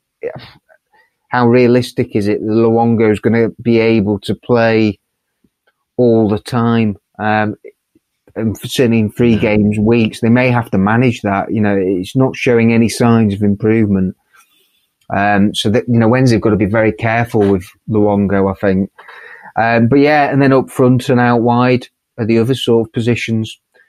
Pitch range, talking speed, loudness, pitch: 105-120 Hz, 180 wpm, -13 LUFS, 115 Hz